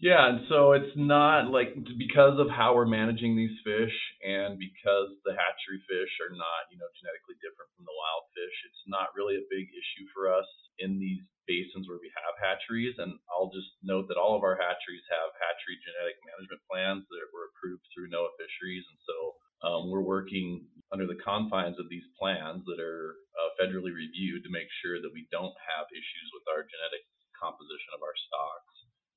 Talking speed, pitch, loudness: 195 wpm, 110 Hz, -30 LUFS